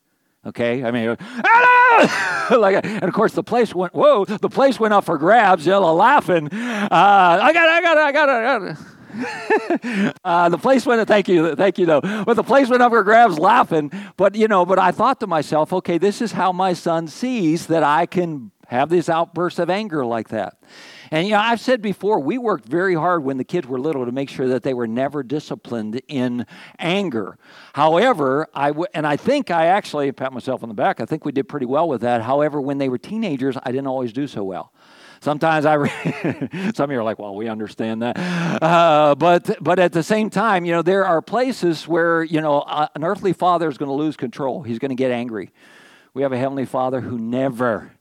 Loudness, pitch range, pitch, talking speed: -18 LUFS, 135-200 Hz, 170 Hz, 220 wpm